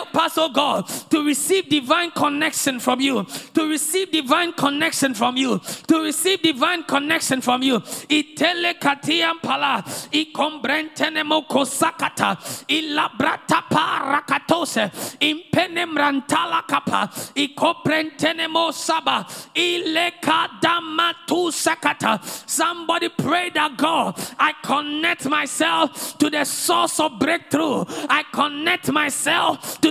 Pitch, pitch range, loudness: 310 Hz, 285-330 Hz, -20 LUFS